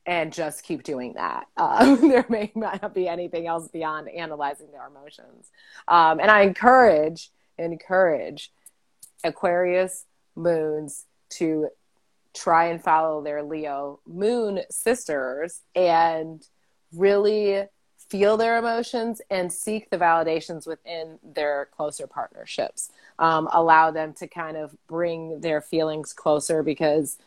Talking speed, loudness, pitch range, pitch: 120 wpm, -23 LUFS, 155-195 Hz, 165 Hz